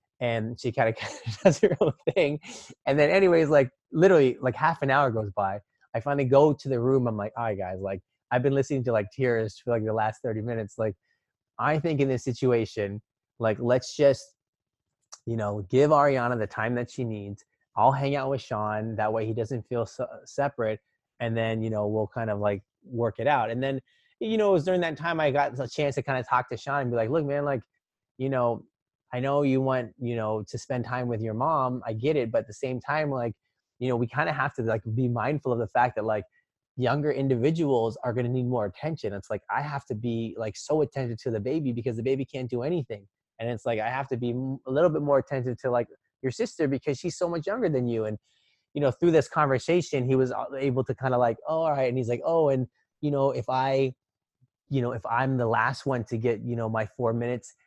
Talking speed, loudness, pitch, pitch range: 245 wpm, -27 LUFS, 125 Hz, 115-140 Hz